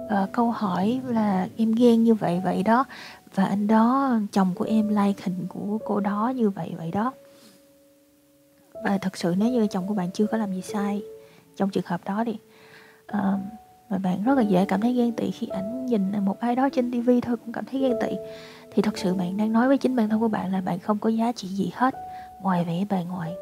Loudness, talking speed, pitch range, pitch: -25 LUFS, 235 wpm, 195-240 Hz, 215 Hz